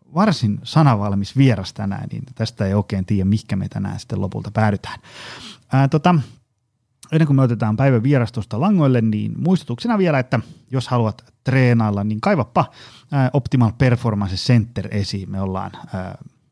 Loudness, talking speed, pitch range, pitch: -19 LUFS, 145 wpm, 105-135 Hz, 120 Hz